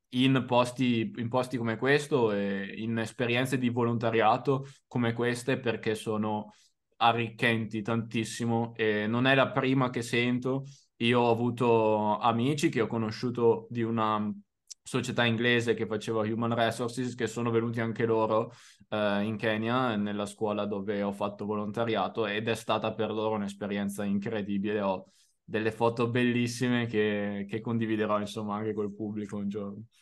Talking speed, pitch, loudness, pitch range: 150 wpm, 115 Hz, -29 LUFS, 105-120 Hz